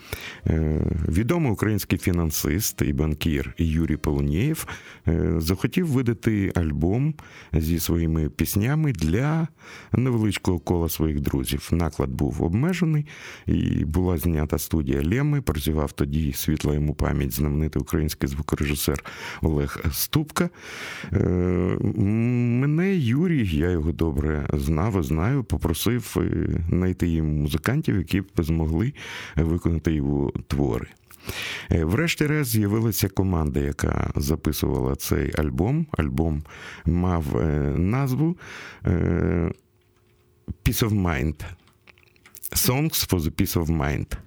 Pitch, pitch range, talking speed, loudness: 85 Hz, 75-115 Hz, 100 wpm, -24 LUFS